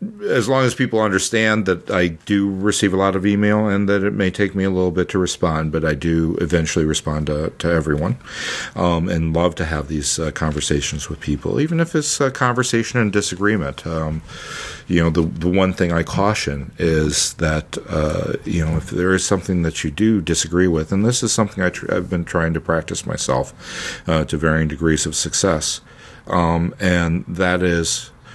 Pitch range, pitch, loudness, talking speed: 80-100 Hz, 85 Hz, -19 LUFS, 200 wpm